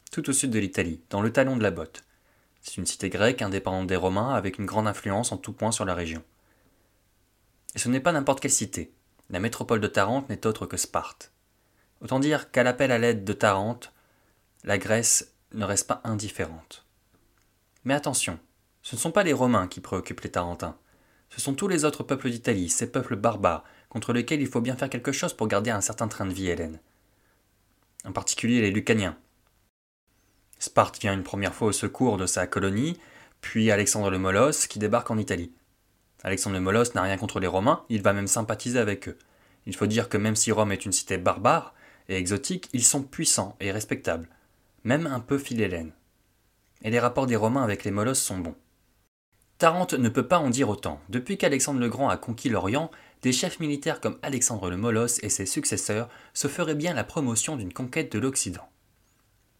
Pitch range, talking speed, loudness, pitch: 95-125 Hz, 195 wpm, -26 LUFS, 110 Hz